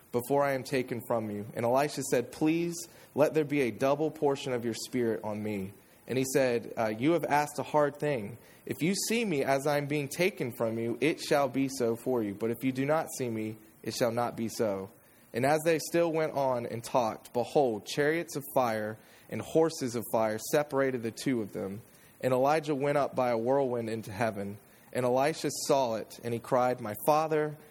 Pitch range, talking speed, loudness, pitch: 115-150 Hz, 215 wpm, -30 LUFS, 130 Hz